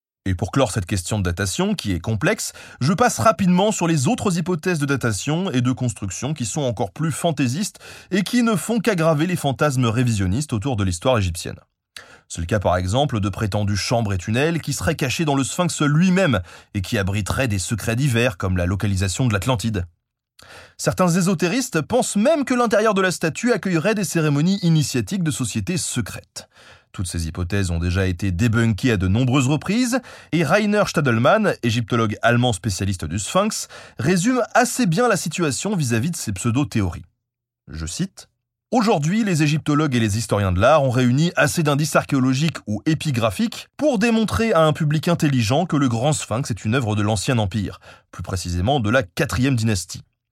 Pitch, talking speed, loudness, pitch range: 130 Hz, 180 wpm, -20 LUFS, 110-170 Hz